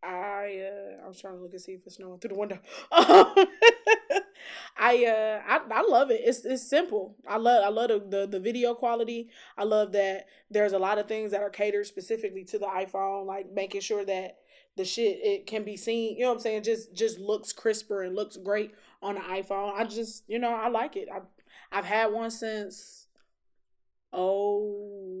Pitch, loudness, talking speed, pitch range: 210 Hz, -27 LUFS, 200 wpm, 195-235 Hz